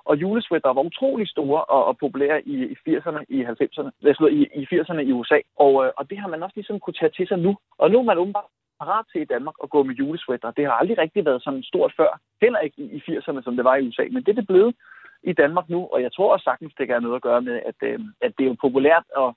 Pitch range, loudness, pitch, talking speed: 135-205 Hz, -22 LUFS, 155 Hz, 265 wpm